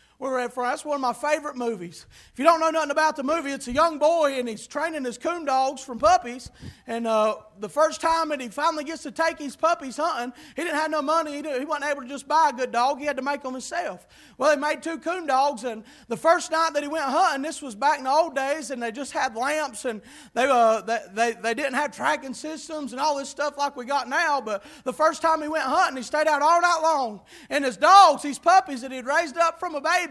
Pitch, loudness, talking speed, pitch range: 290 Hz, -24 LUFS, 265 wpm, 255-315 Hz